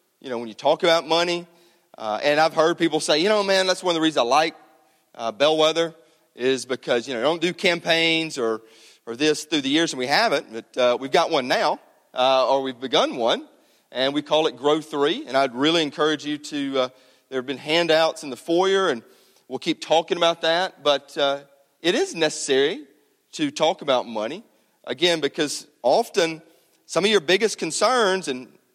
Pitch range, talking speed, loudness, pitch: 140-170 Hz, 200 wpm, -22 LUFS, 155 Hz